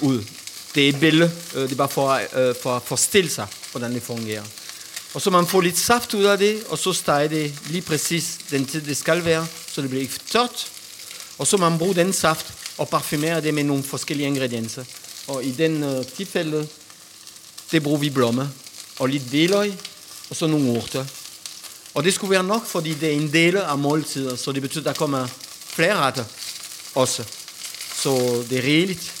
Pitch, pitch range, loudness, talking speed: 150 Hz, 135-170 Hz, -22 LUFS, 195 wpm